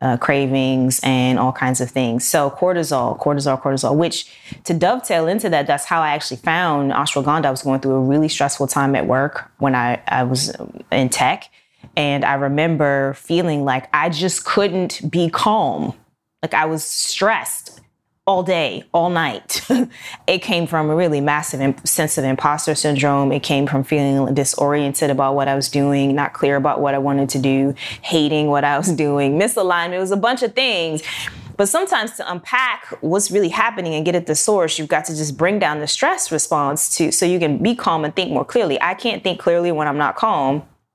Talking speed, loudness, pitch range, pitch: 200 wpm, -18 LUFS, 140-170 Hz, 150 Hz